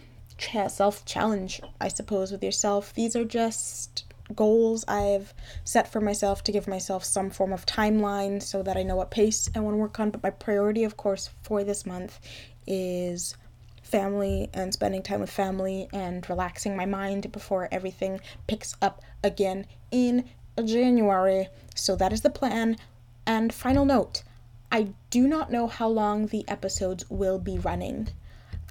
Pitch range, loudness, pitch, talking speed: 185-215 Hz, -27 LUFS, 195 Hz, 160 wpm